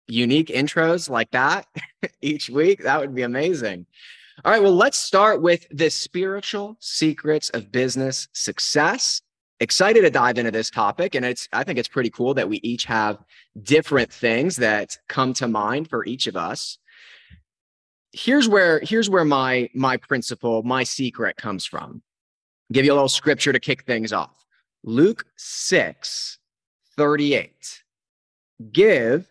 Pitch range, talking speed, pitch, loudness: 125-165 Hz, 150 wpm, 140 Hz, -20 LUFS